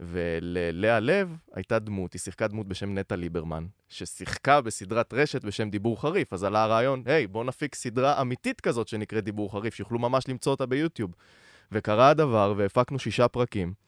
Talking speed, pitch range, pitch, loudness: 170 wpm, 100-130 Hz, 110 Hz, -27 LUFS